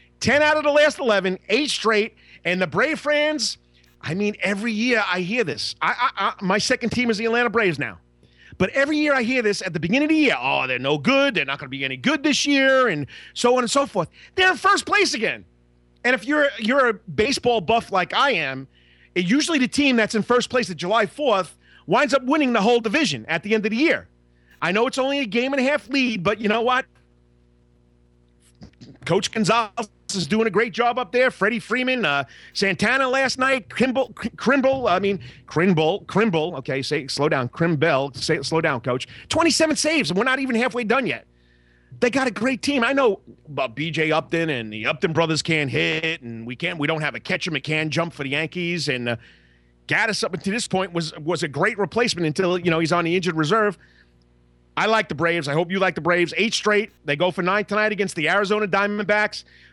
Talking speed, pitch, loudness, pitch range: 225 wpm, 200 Hz, -21 LUFS, 155-245 Hz